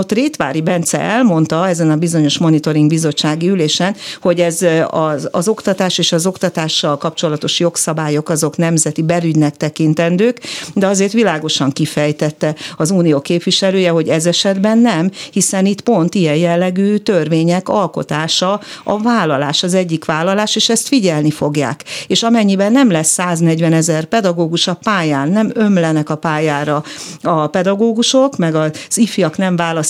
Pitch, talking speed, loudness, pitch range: 170 Hz, 140 wpm, -14 LUFS, 155-195 Hz